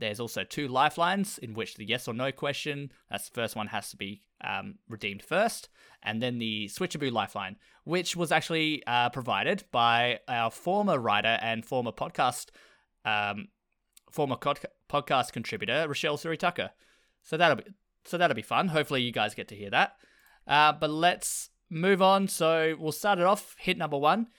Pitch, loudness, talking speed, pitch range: 145 Hz, -29 LUFS, 175 wpm, 115-175 Hz